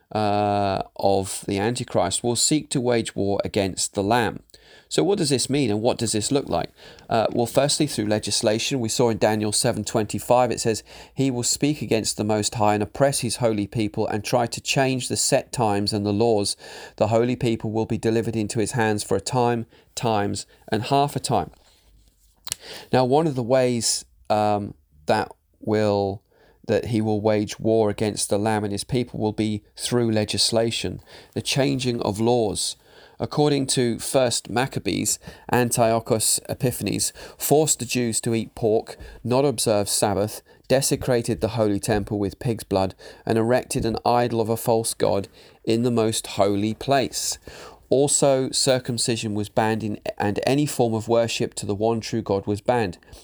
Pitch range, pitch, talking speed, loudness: 105-125 Hz, 115 Hz, 175 wpm, -23 LUFS